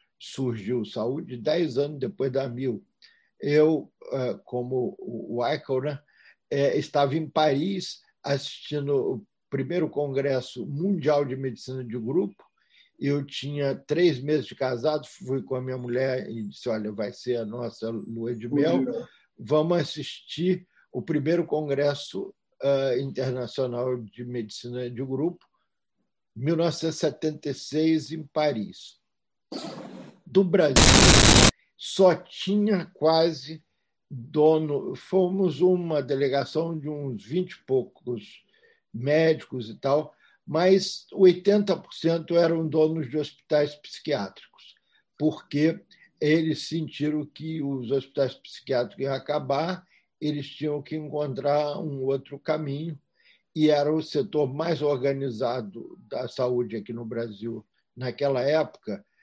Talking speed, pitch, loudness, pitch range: 110 wpm, 145 Hz, -21 LUFS, 130-160 Hz